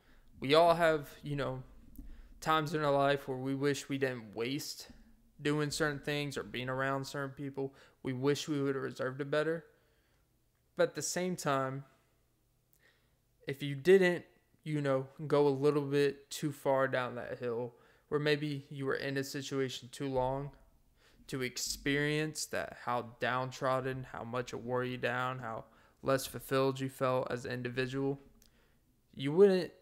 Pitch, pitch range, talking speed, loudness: 135 Hz, 130-145 Hz, 160 wpm, -34 LUFS